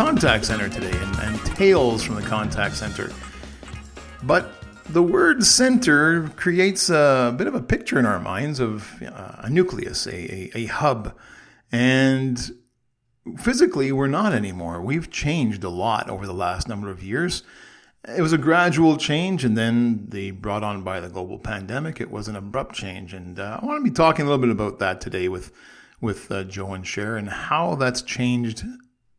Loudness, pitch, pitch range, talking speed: -22 LUFS, 115 Hz, 95-150 Hz, 185 wpm